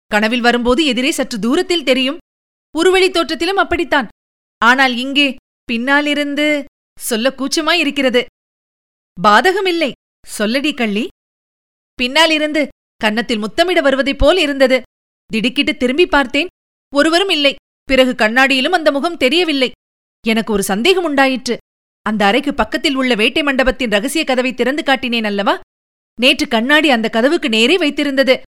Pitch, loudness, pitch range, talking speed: 275 Hz, -14 LUFS, 245-305 Hz, 110 wpm